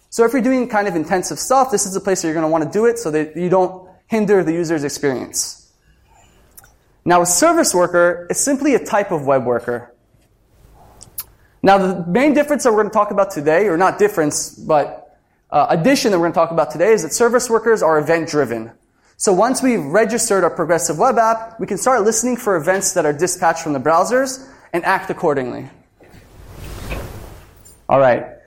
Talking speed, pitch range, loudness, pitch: 200 wpm, 150-220 Hz, -16 LUFS, 180 Hz